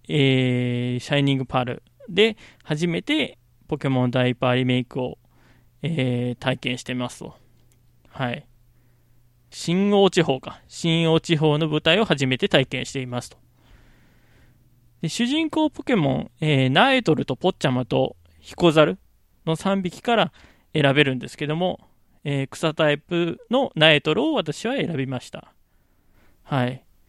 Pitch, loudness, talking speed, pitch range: 135 Hz, -22 LUFS, 270 characters per minute, 125-165 Hz